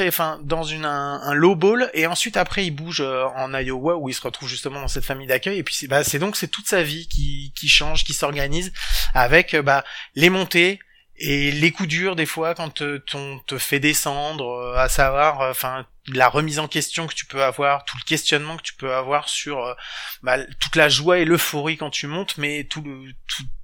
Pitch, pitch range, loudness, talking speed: 145 Hz, 135-165 Hz, -21 LUFS, 230 wpm